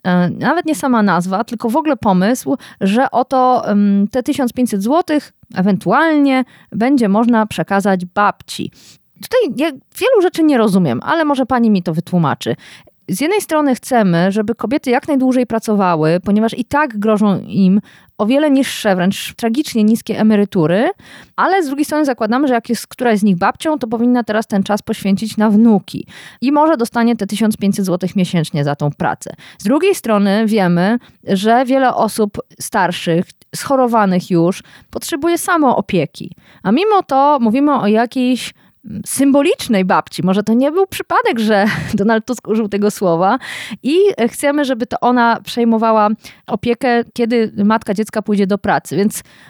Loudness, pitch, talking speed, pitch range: -15 LUFS, 225 Hz, 155 wpm, 200-265 Hz